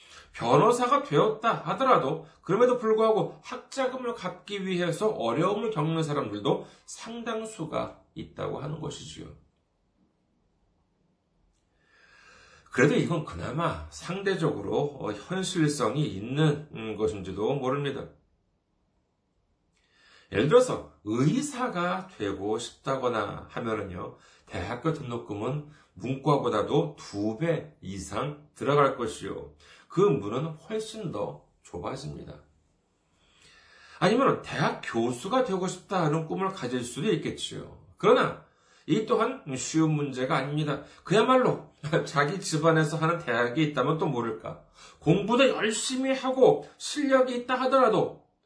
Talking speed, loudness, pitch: 255 characters per minute, -27 LUFS, 155 Hz